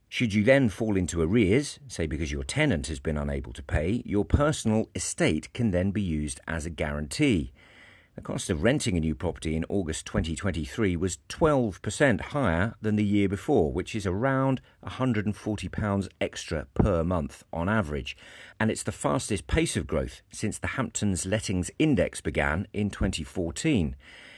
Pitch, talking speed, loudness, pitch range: 95 Hz, 160 wpm, -28 LUFS, 80-110 Hz